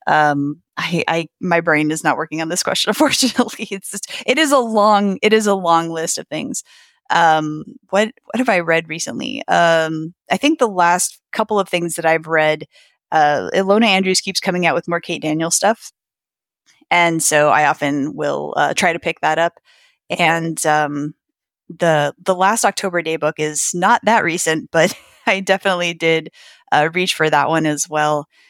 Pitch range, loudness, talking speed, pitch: 155-200 Hz, -17 LUFS, 185 wpm, 170 Hz